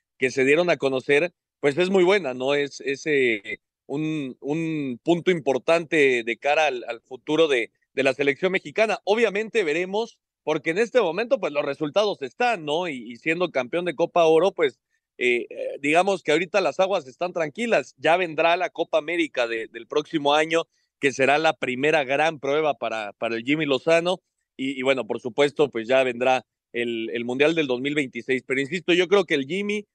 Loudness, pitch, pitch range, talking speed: -23 LUFS, 155 Hz, 135-180 Hz, 190 wpm